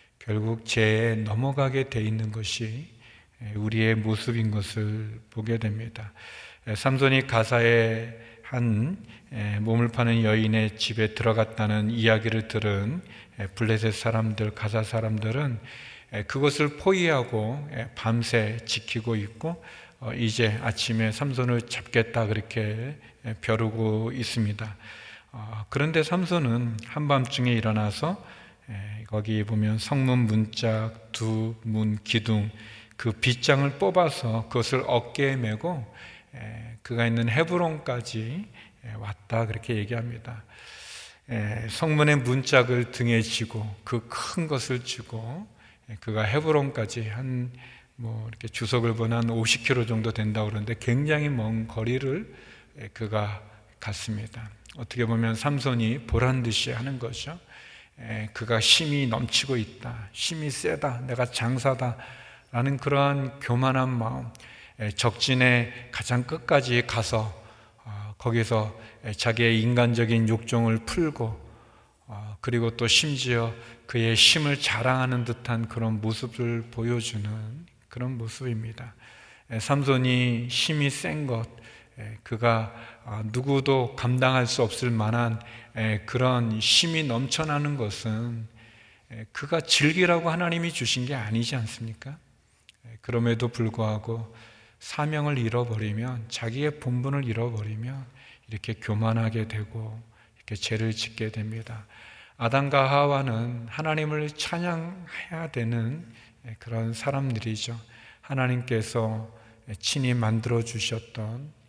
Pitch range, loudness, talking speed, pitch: 110-125 Hz, -26 LUFS, 240 characters per minute, 115 Hz